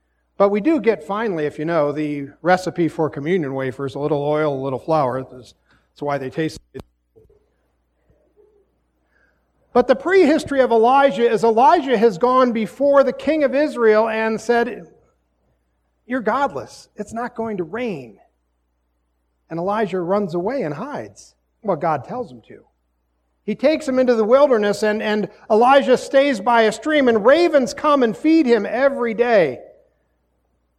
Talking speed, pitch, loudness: 155 wpm, 210 Hz, -18 LUFS